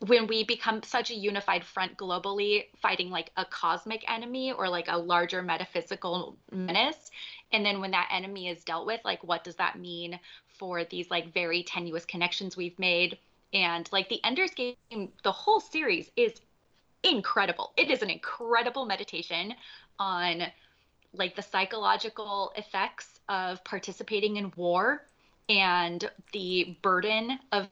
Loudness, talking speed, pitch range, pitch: -29 LUFS, 145 wpm, 175-220 Hz, 190 Hz